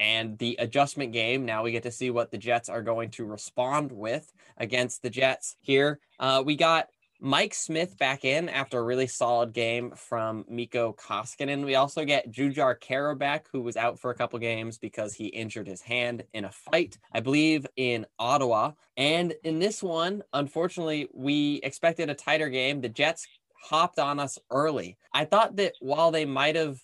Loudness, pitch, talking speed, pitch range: -28 LUFS, 130 Hz, 185 wpm, 120-145 Hz